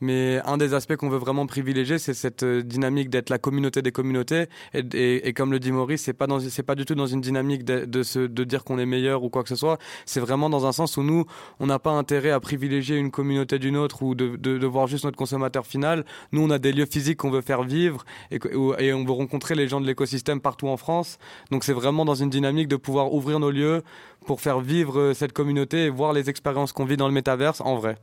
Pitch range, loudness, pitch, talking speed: 130-145 Hz, -24 LUFS, 140 Hz, 260 wpm